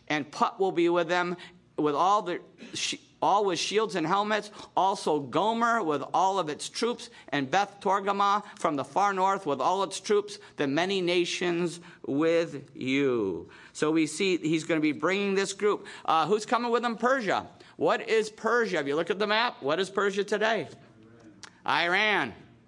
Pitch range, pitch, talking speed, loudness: 165-210 Hz, 195 Hz, 175 wpm, -27 LUFS